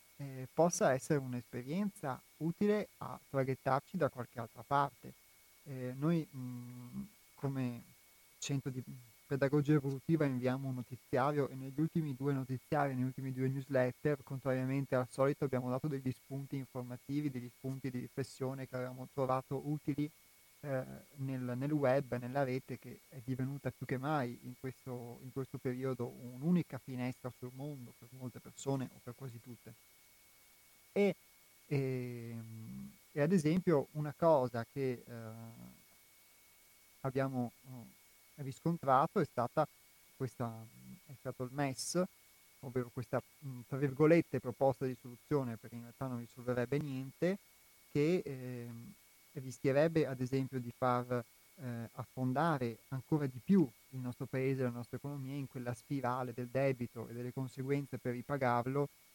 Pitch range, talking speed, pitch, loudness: 125-140 Hz, 135 wpm, 130 Hz, -38 LUFS